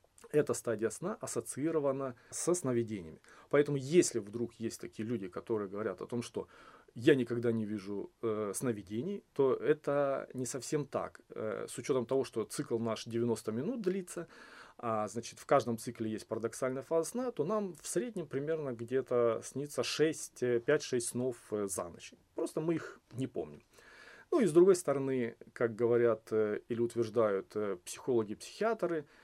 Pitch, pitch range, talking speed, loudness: 125 Hz, 115-150 Hz, 155 wpm, -35 LUFS